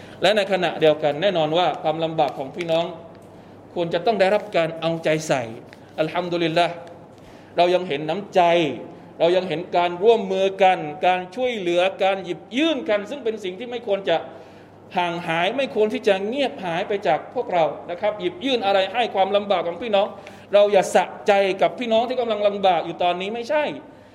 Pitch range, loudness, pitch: 170-205 Hz, -21 LUFS, 185 Hz